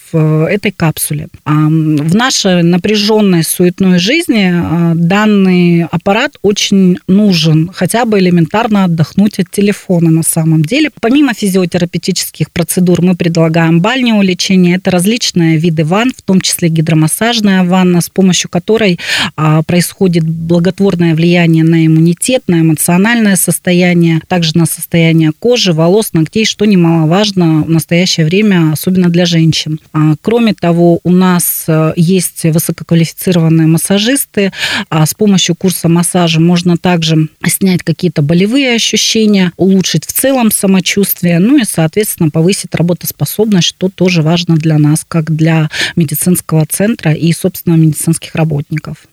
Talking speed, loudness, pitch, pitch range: 125 wpm, -10 LUFS, 175 Hz, 165-195 Hz